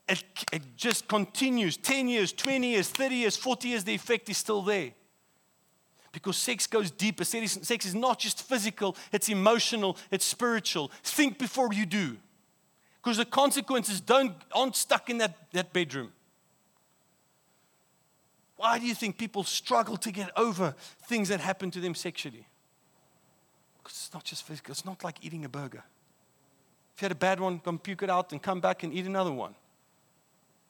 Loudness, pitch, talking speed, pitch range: -29 LUFS, 200 Hz, 170 wpm, 180-230 Hz